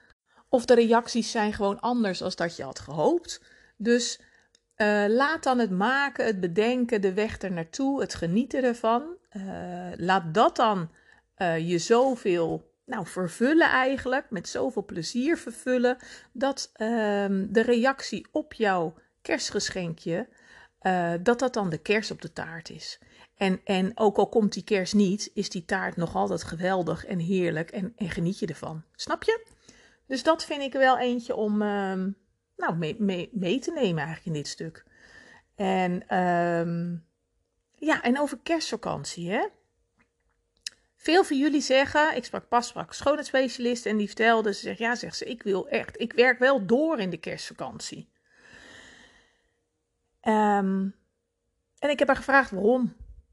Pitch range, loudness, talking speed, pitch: 185-255 Hz, -26 LUFS, 155 wpm, 215 Hz